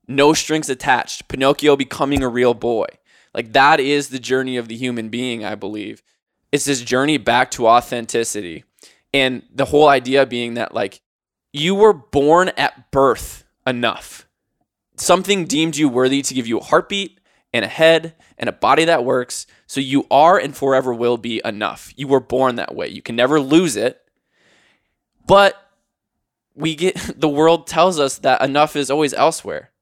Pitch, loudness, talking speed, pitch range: 140 Hz, -17 LUFS, 170 wpm, 125-155 Hz